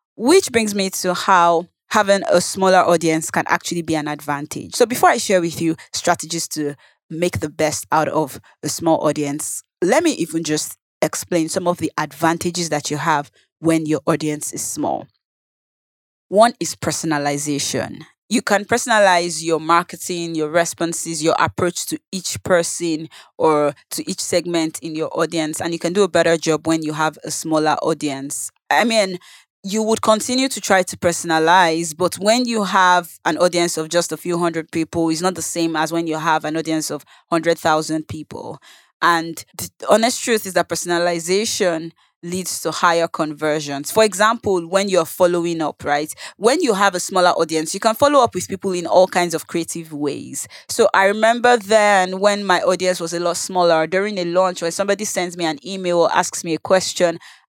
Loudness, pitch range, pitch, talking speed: -18 LUFS, 160-190 Hz, 170 Hz, 185 wpm